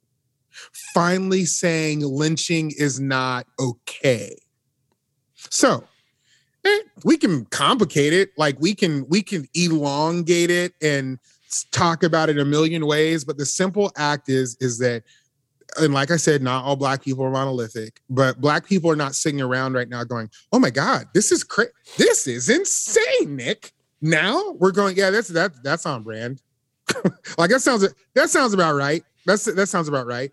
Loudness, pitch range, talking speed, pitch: -20 LUFS, 135-185 Hz, 165 wpm, 155 Hz